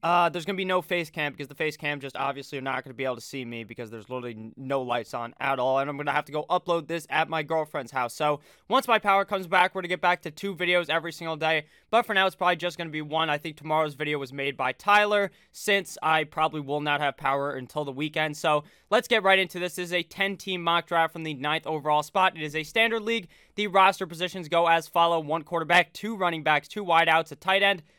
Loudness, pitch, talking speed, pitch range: -26 LUFS, 160 Hz, 265 wpm, 145-180 Hz